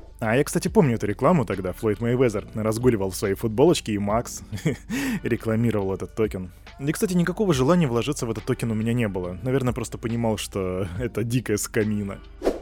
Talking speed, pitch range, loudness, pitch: 175 wpm, 105-130 Hz, -24 LUFS, 115 Hz